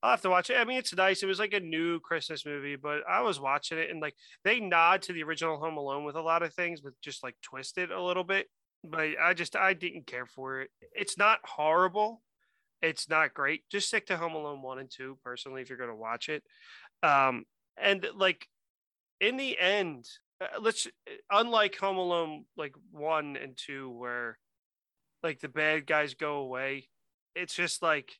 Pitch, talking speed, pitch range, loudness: 160 Hz, 200 wpm, 140-190 Hz, -30 LUFS